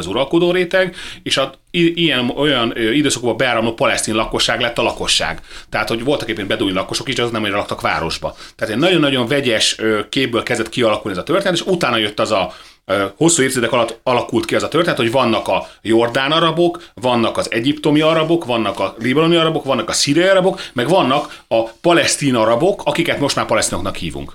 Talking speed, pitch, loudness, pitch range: 190 wpm, 130 Hz, -16 LUFS, 115-165 Hz